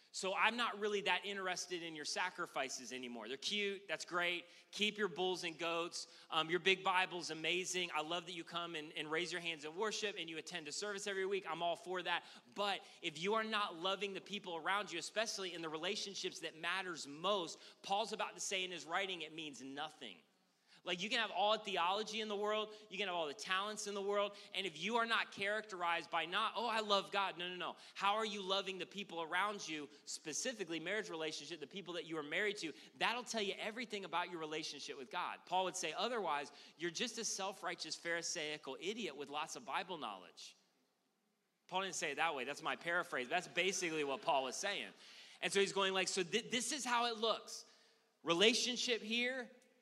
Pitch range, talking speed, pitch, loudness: 170-210 Hz, 215 wpm, 185 Hz, -40 LUFS